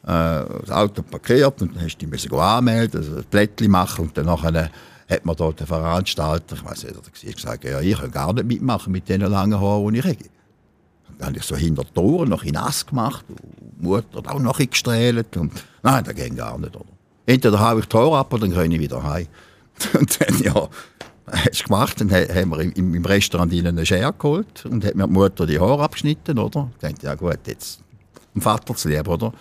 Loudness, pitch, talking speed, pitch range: -20 LUFS, 95 Hz, 210 wpm, 80-115 Hz